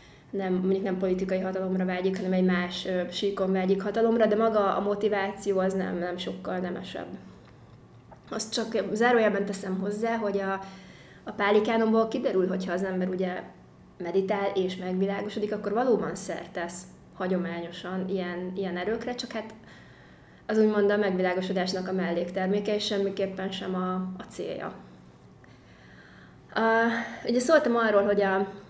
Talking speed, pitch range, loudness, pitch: 135 wpm, 185-210 Hz, -27 LUFS, 195 Hz